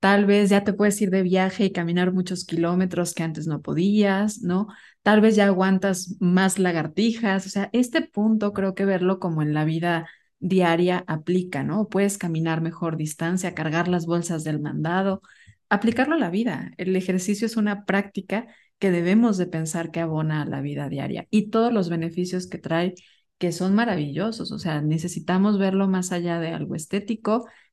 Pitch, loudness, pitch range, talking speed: 185 Hz, -23 LUFS, 170-205 Hz, 180 wpm